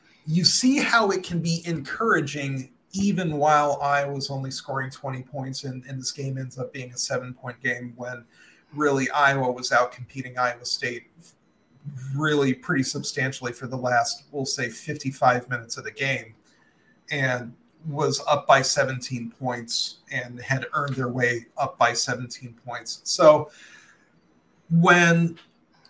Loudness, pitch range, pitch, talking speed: -24 LUFS, 125-145 Hz, 130 Hz, 150 wpm